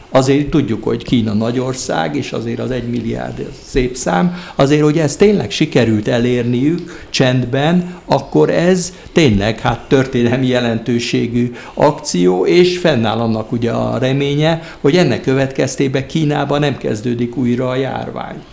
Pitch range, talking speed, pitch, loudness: 120-145 Hz, 135 wpm, 130 Hz, -15 LUFS